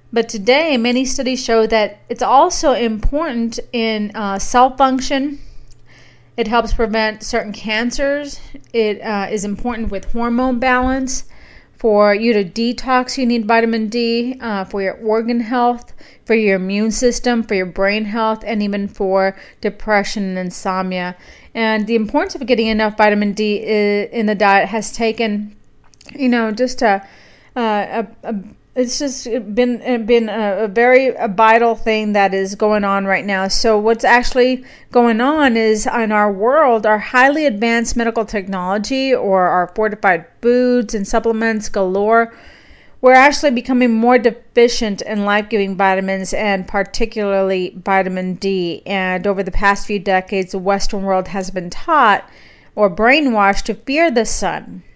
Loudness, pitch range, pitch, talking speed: -16 LUFS, 200-240 Hz, 225 Hz, 150 wpm